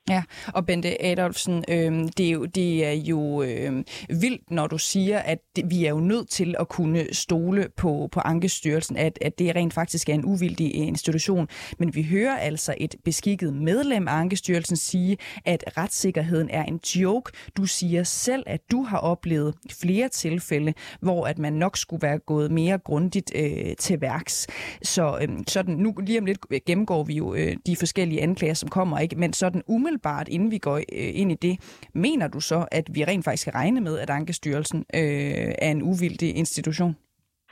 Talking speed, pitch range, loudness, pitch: 185 wpm, 155-185 Hz, -25 LUFS, 170 Hz